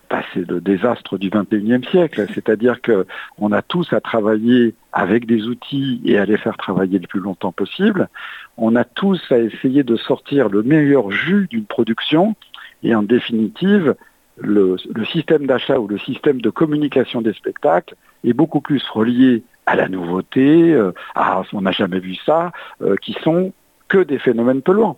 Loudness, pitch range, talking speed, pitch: -17 LUFS, 105-150 Hz, 170 wpm, 120 Hz